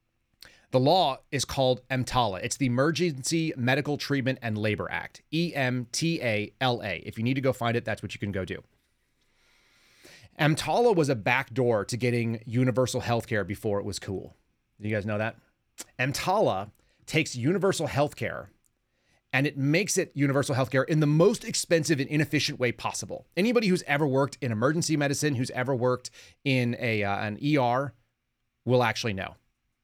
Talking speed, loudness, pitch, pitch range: 160 wpm, -27 LUFS, 125 Hz, 115-145 Hz